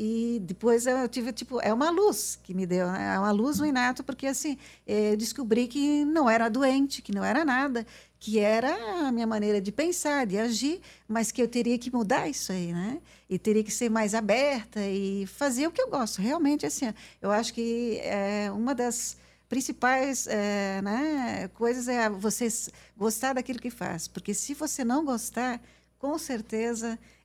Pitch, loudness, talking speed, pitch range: 235 Hz, -28 LUFS, 185 wpm, 215-270 Hz